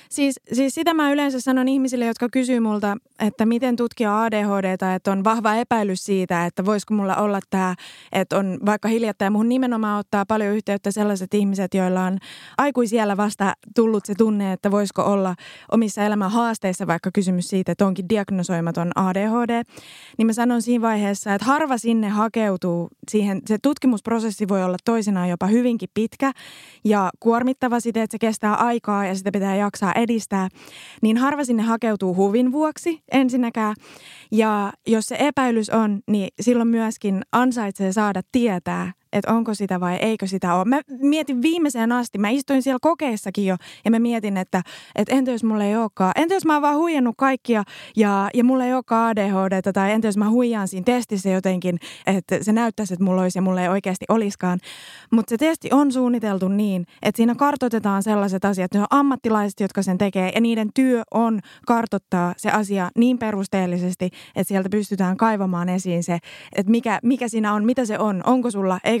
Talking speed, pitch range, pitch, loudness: 180 wpm, 195-235 Hz, 215 Hz, -21 LUFS